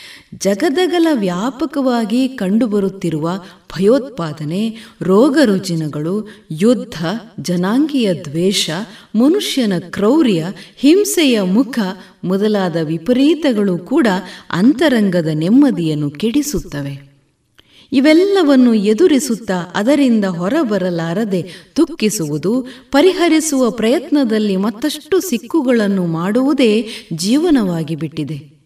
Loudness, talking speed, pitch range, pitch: -15 LUFS, 60 wpm, 175-265 Hz, 215 Hz